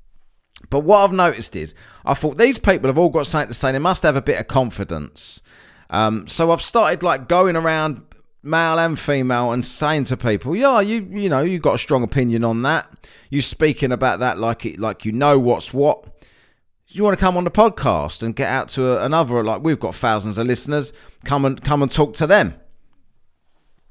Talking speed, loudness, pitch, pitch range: 210 wpm, -18 LUFS, 140 Hz, 115-165 Hz